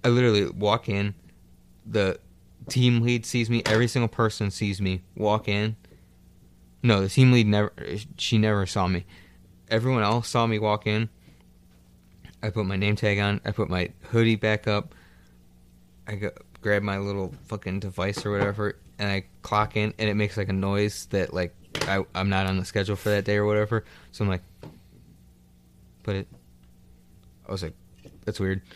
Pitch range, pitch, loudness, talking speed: 90-110 Hz, 100 Hz, -26 LUFS, 175 wpm